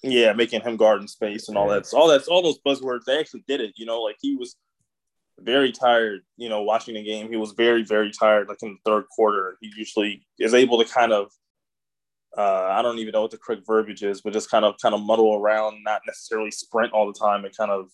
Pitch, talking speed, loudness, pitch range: 110 Hz, 250 wpm, -22 LUFS, 105-120 Hz